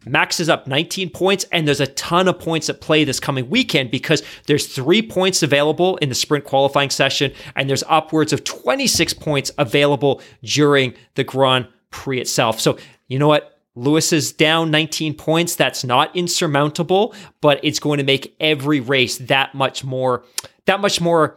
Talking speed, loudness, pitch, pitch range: 175 wpm, -17 LUFS, 145 Hz, 135-160 Hz